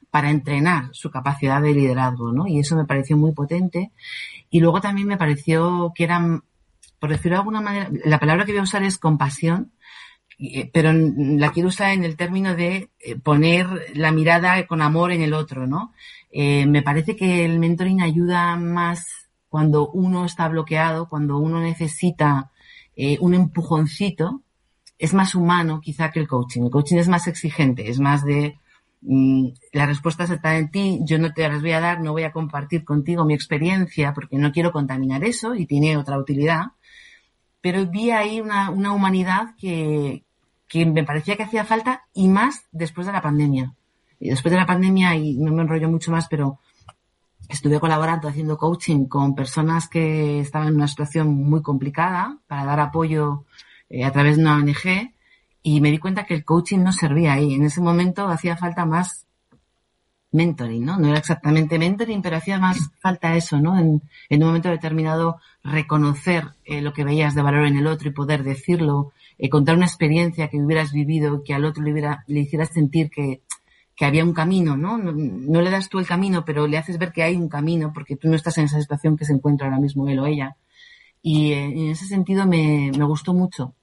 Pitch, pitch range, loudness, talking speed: 160 Hz, 145-175 Hz, -20 LUFS, 195 wpm